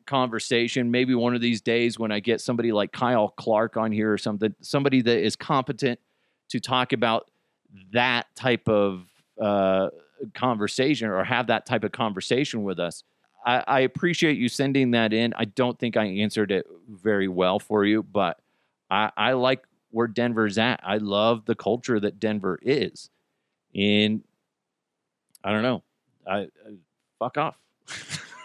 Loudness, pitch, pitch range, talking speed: -24 LUFS, 115 Hz, 105-125 Hz, 160 wpm